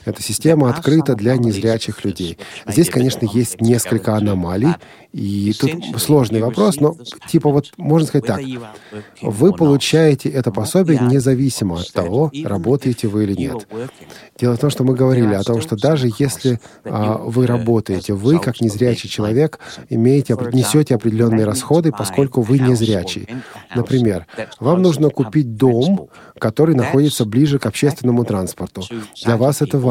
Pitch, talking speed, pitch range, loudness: 125 Hz, 145 wpm, 110-140 Hz, -16 LUFS